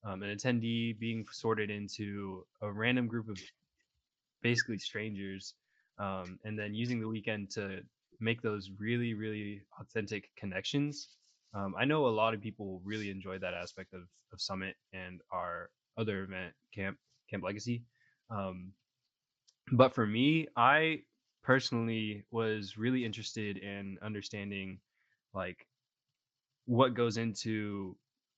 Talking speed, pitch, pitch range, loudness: 130 wpm, 110 Hz, 100-120 Hz, -35 LUFS